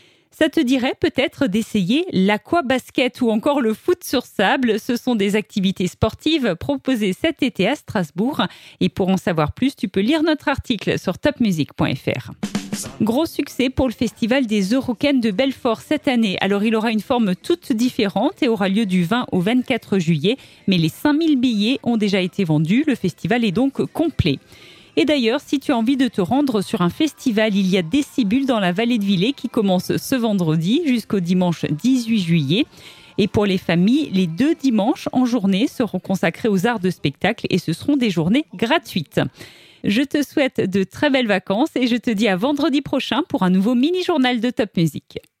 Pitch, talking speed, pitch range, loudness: 235 Hz, 195 wpm, 195-270 Hz, -19 LUFS